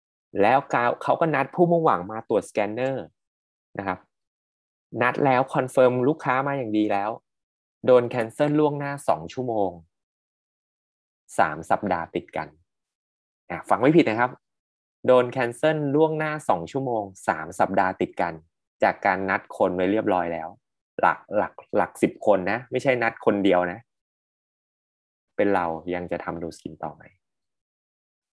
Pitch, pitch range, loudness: 120 Hz, 90-135 Hz, -24 LUFS